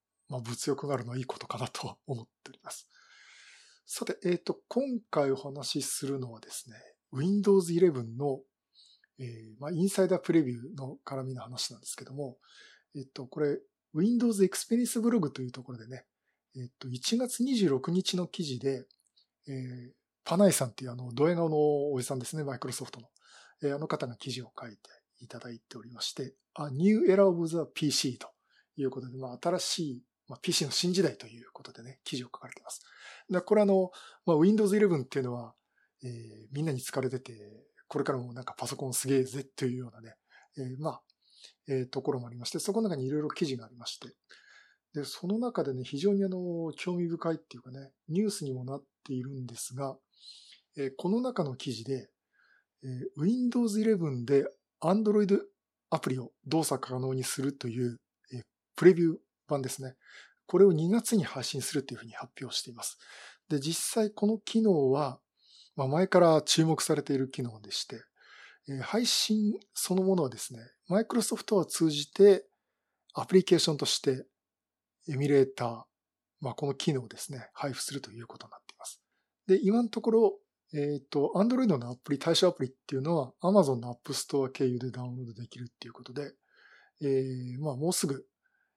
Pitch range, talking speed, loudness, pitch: 130-185 Hz, 380 characters per minute, -30 LUFS, 140 Hz